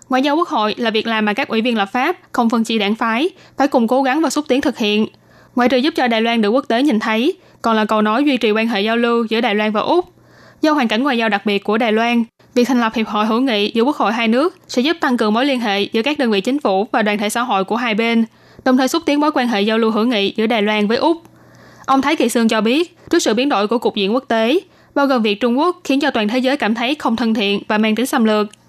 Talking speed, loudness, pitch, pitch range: 310 wpm, -16 LUFS, 235 Hz, 220-270 Hz